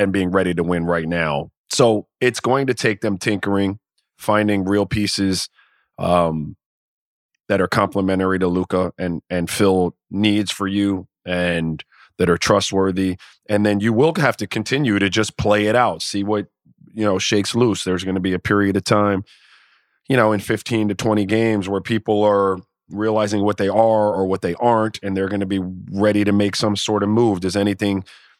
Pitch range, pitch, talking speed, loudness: 95-105 Hz, 100 Hz, 190 wpm, -19 LUFS